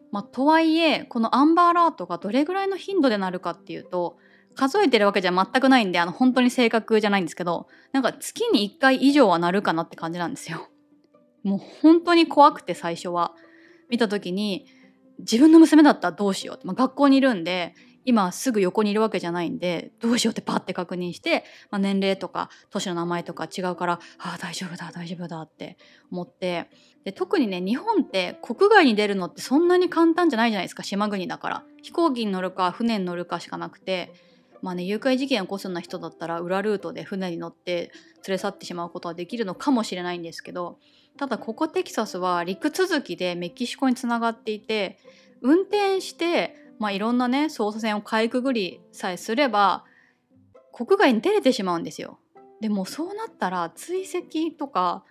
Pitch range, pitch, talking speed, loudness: 180-280 Hz, 215 Hz, 395 characters per minute, -23 LUFS